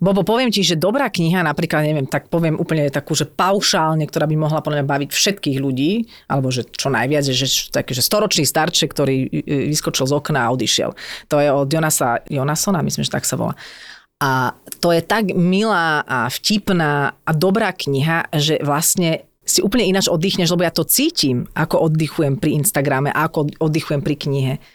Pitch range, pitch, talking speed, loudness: 145-180 Hz, 155 Hz, 180 wpm, -18 LUFS